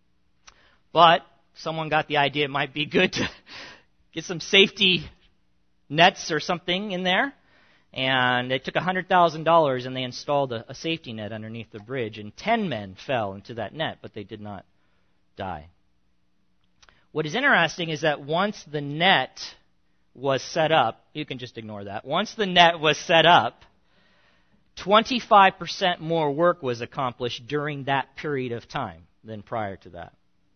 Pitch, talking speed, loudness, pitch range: 145 Hz, 155 wpm, -23 LUFS, 115-170 Hz